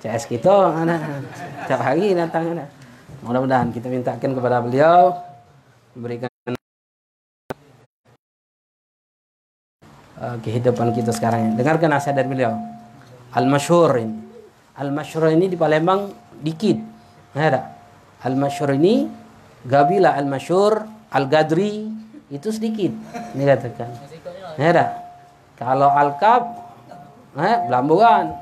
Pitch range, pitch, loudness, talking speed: 125-175 Hz, 140 Hz, -19 LUFS, 95 wpm